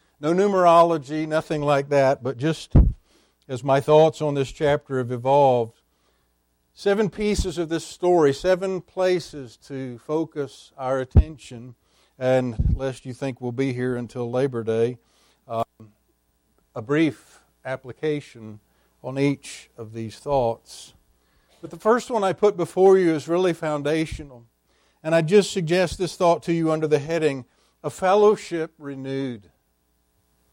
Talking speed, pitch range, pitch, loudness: 140 wpm, 120-165 Hz, 140 Hz, -22 LUFS